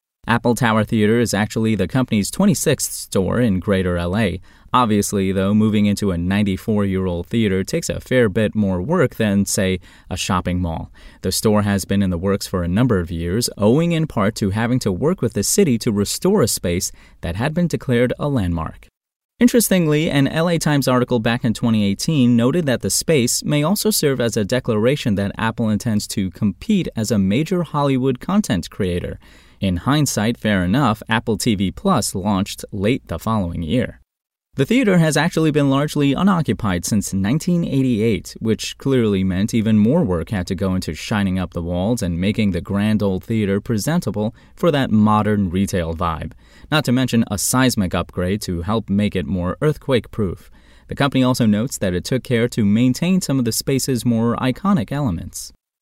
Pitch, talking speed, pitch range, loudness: 110 Hz, 180 wpm, 95-130 Hz, -19 LUFS